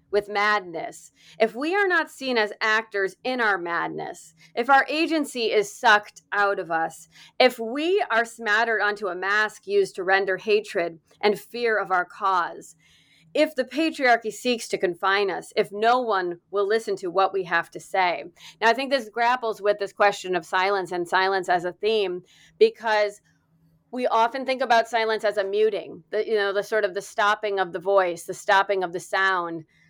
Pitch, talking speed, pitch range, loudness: 210 Hz, 190 wpm, 190-230 Hz, -23 LUFS